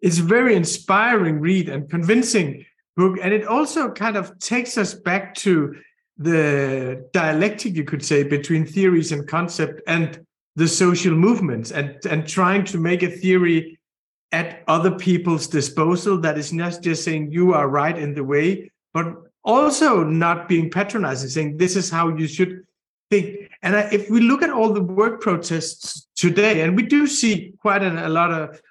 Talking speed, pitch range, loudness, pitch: 175 wpm, 160-200 Hz, -20 LUFS, 175 Hz